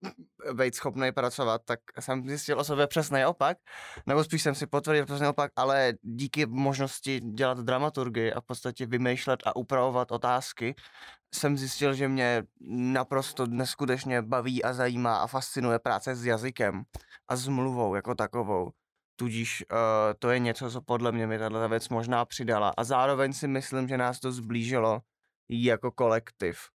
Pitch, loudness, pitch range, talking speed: 125 Hz, -29 LUFS, 120-135 Hz, 160 wpm